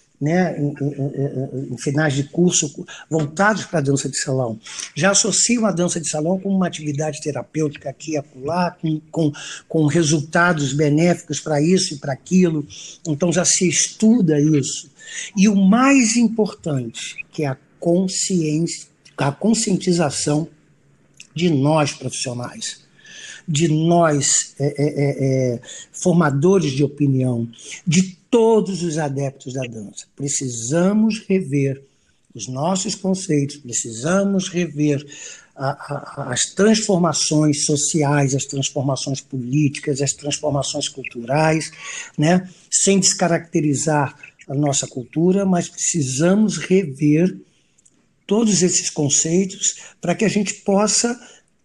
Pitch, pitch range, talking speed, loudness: 155 Hz, 140-185 Hz, 120 wpm, -19 LUFS